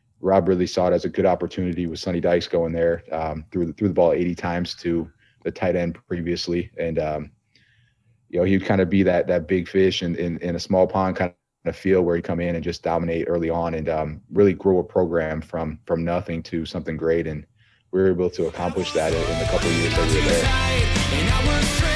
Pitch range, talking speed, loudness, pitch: 85-95 Hz, 230 wpm, -22 LUFS, 90 Hz